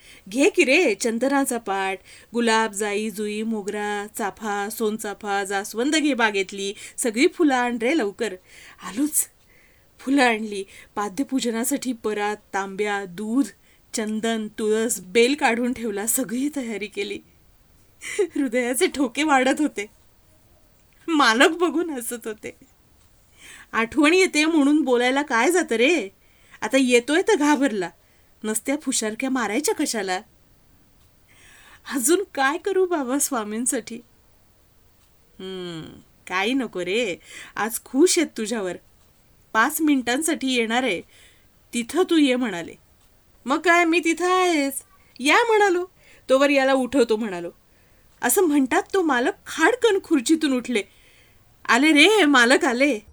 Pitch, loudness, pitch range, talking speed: 250 Hz, -21 LUFS, 215-295 Hz, 115 wpm